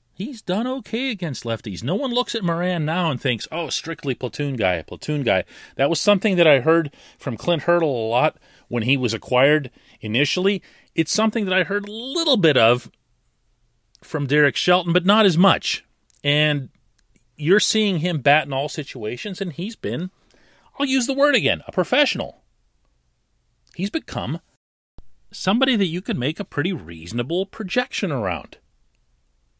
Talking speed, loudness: 165 wpm, -21 LUFS